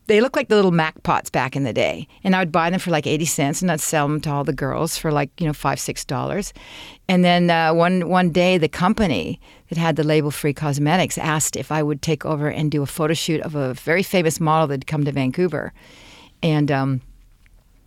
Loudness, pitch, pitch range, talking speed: -20 LUFS, 155 Hz, 145-175 Hz, 235 wpm